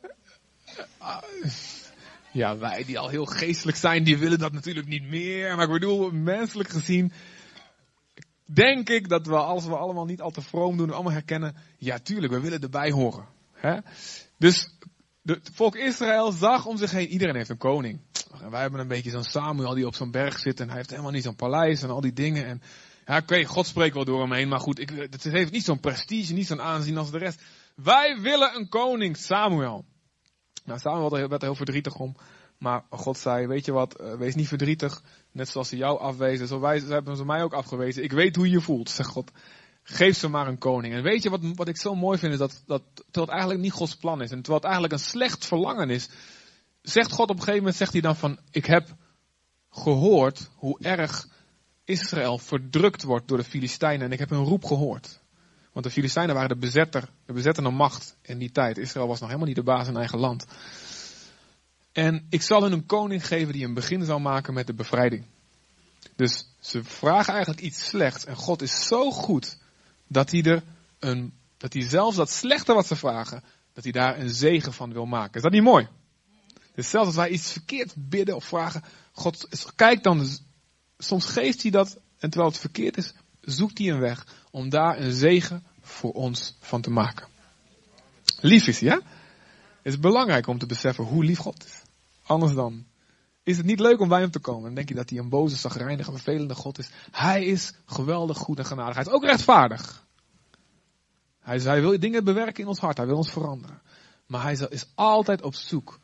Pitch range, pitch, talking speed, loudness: 130-180 Hz, 150 Hz, 205 wpm, -25 LUFS